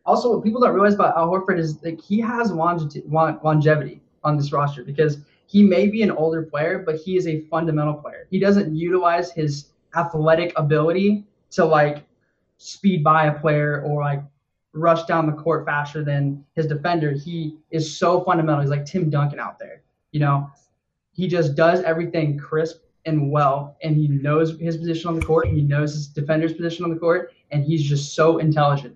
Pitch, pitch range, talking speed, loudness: 160 Hz, 150-170 Hz, 195 wpm, -21 LUFS